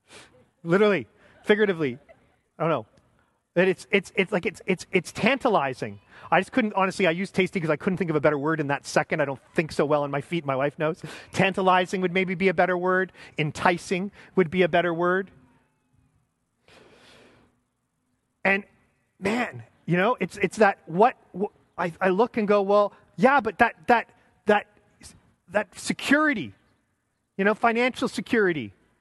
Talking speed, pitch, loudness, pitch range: 170 wpm, 185 Hz, -24 LUFS, 155-200 Hz